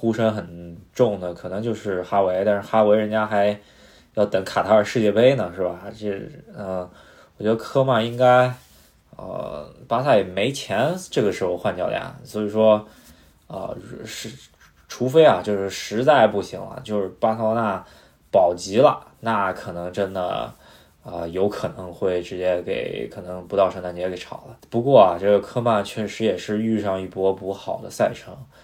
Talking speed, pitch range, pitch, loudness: 255 characters per minute, 90-110 Hz, 100 Hz, -21 LUFS